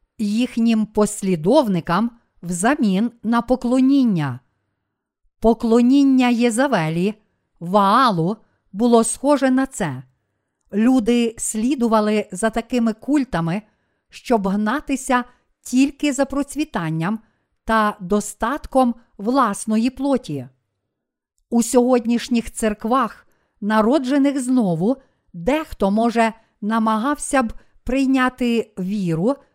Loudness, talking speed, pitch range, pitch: -19 LUFS, 75 wpm, 205-255 Hz, 230 Hz